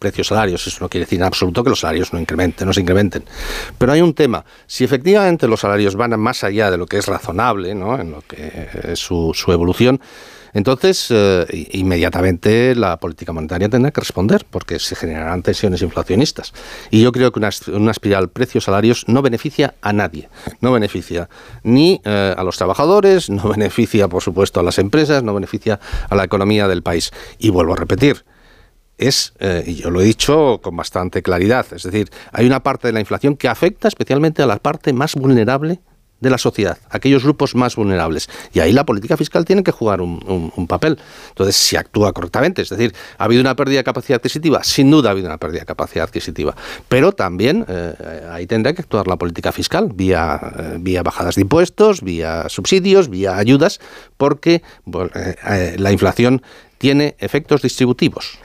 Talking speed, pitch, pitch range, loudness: 195 wpm, 105 Hz, 90-130 Hz, -16 LUFS